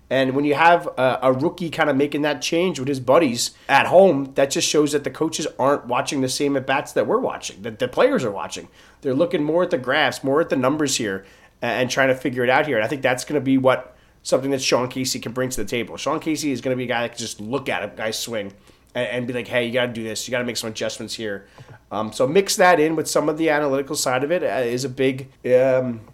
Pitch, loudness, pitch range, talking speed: 130 Hz, -21 LUFS, 120-145 Hz, 275 wpm